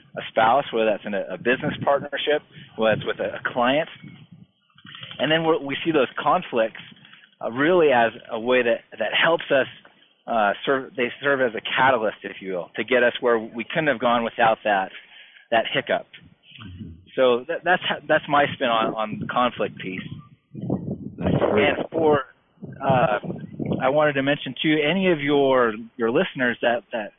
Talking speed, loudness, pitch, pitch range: 175 wpm, -22 LUFS, 130 Hz, 115-150 Hz